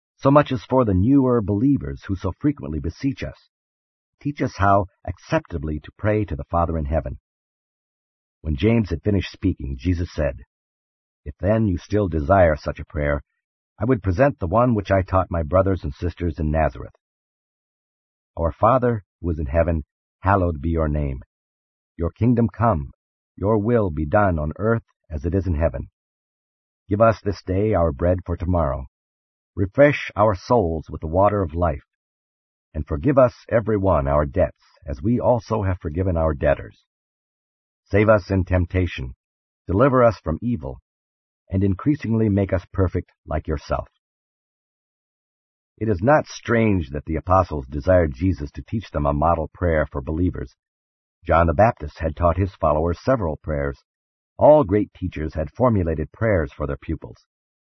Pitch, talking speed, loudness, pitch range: 90 Hz, 160 wpm, -21 LUFS, 75-105 Hz